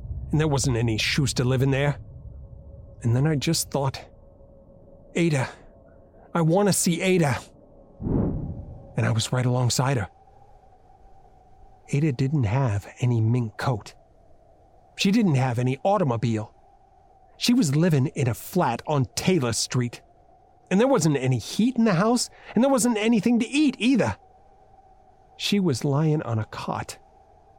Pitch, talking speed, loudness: 145 Hz, 145 wpm, -24 LUFS